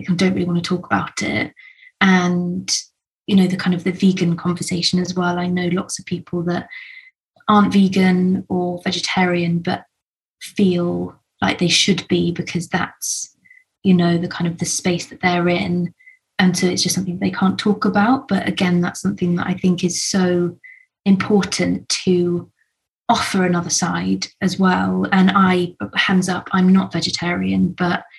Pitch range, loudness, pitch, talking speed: 175-190 Hz, -18 LUFS, 180 Hz, 170 wpm